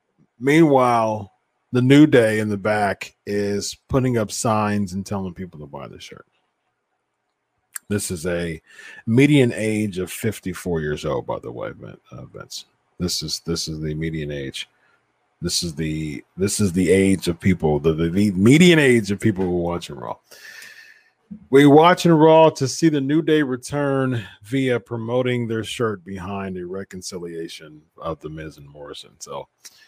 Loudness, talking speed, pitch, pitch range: -19 LUFS, 165 wpm, 105 Hz, 85-130 Hz